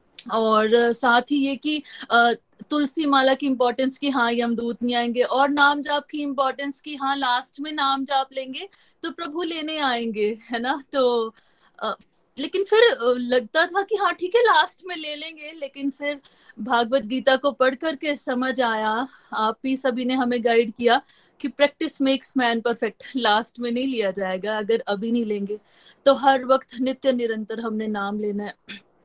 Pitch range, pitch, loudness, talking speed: 235-285 Hz, 260 Hz, -22 LUFS, 180 wpm